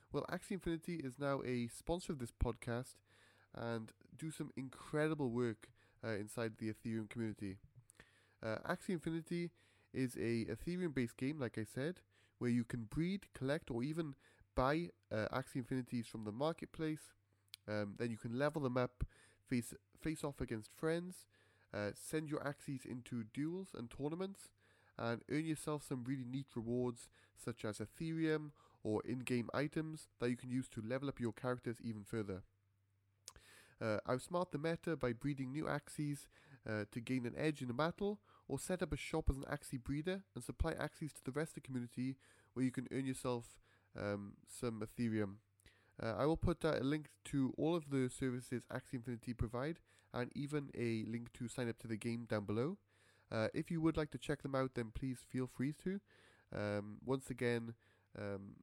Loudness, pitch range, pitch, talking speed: -43 LUFS, 110-150 Hz, 125 Hz, 180 wpm